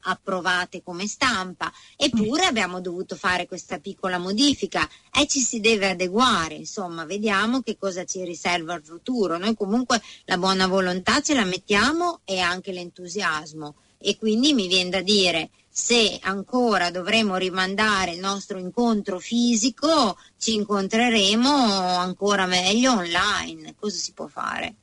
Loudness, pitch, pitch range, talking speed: -22 LUFS, 195 Hz, 180-225 Hz, 140 wpm